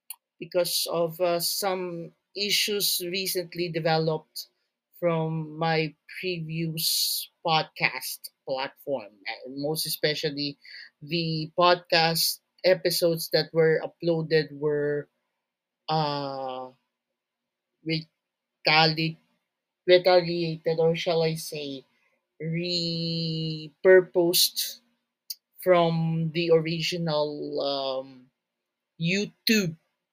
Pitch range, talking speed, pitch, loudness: 155-175 Hz, 70 wpm, 165 Hz, -26 LUFS